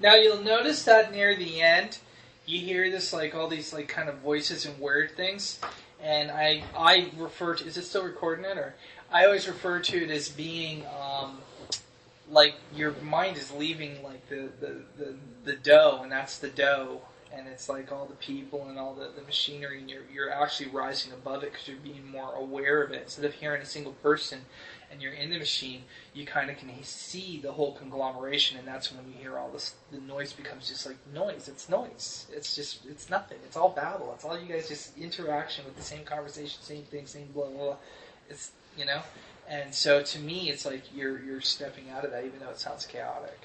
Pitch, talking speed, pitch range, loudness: 145 Hz, 215 wpm, 135-155 Hz, -28 LUFS